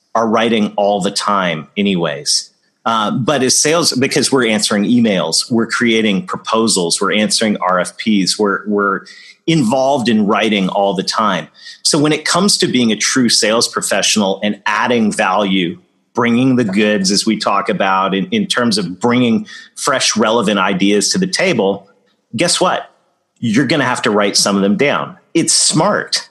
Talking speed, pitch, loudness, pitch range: 165 wpm, 110 Hz, -14 LUFS, 100-130 Hz